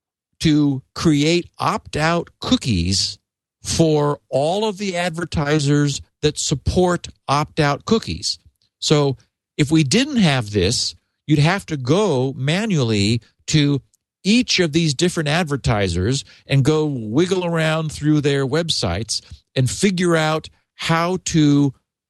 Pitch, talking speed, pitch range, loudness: 150 Hz, 120 wpm, 120-165 Hz, -19 LUFS